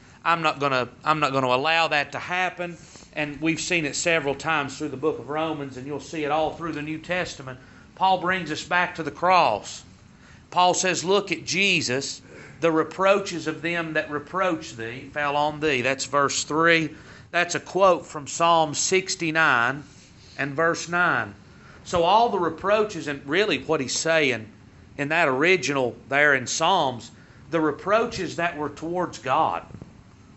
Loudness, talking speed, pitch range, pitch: -23 LUFS, 165 wpm, 140-170 Hz, 155 Hz